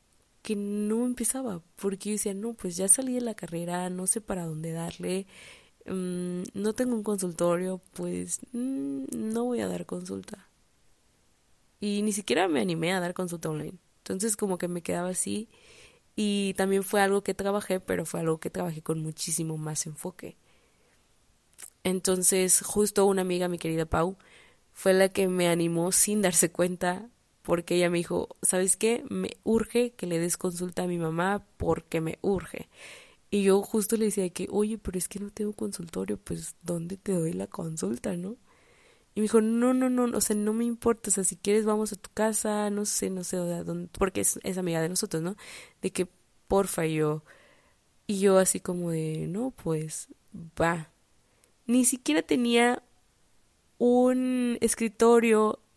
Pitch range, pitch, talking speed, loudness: 170-215 Hz, 190 Hz, 175 wpm, -28 LUFS